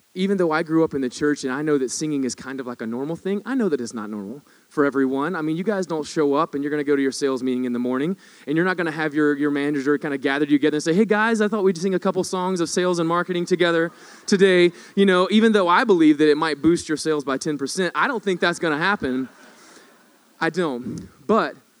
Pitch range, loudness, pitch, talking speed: 140-185 Hz, -21 LUFS, 160 Hz, 280 wpm